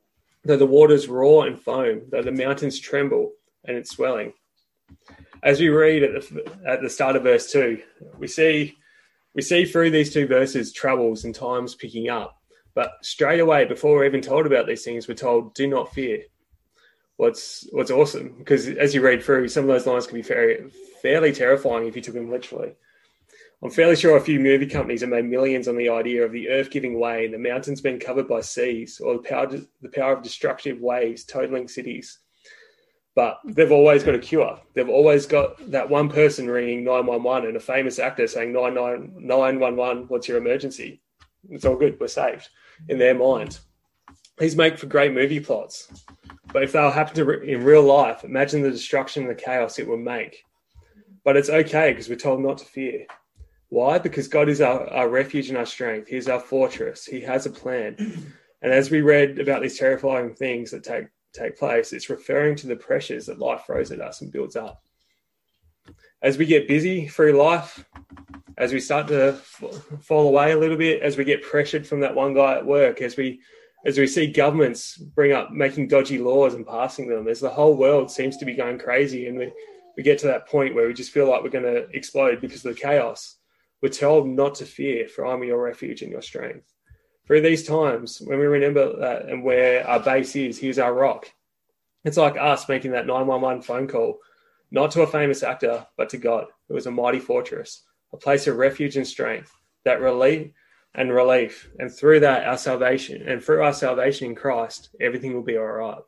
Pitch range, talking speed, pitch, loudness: 125-155 Hz, 205 wpm, 140 Hz, -21 LUFS